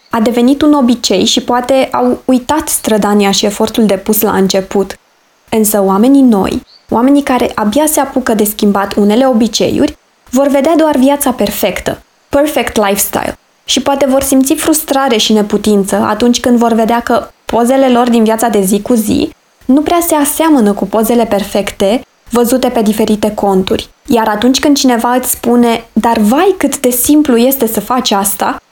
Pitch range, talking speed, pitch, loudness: 215-270 Hz, 165 wpm, 240 Hz, -10 LUFS